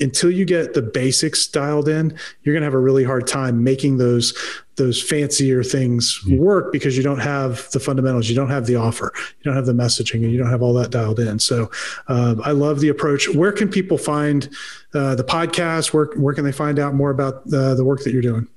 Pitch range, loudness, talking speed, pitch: 125-150 Hz, -18 LUFS, 230 wpm, 135 Hz